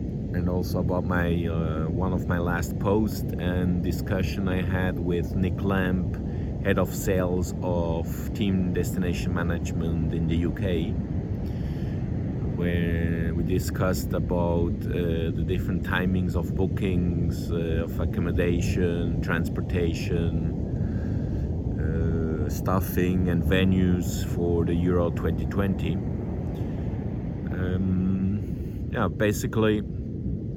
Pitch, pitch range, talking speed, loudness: 90 Hz, 85-95 Hz, 105 wpm, -26 LUFS